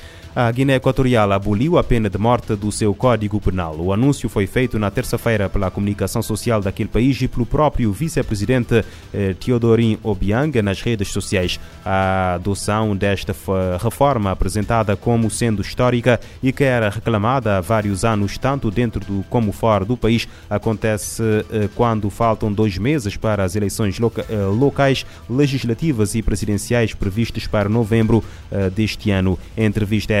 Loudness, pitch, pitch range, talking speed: -19 LUFS, 110 Hz, 100-120 Hz, 145 wpm